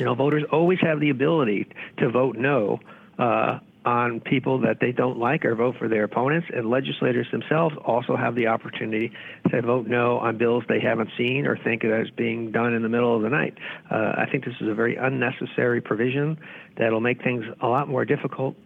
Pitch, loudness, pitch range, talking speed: 120 Hz, -23 LUFS, 115-135 Hz, 210 wpm